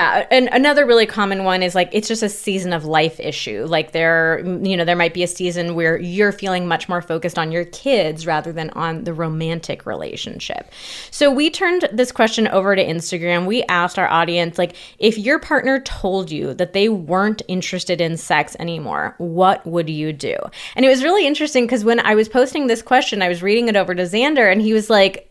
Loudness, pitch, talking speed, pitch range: -17 LUFS, 185 Hz, 215 wpm, 170-225 Hz